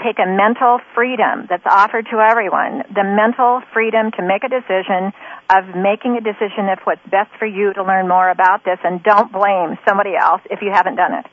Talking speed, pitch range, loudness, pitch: 205 wpm, 190-225 Hz, -15 LUFS, 205 Hz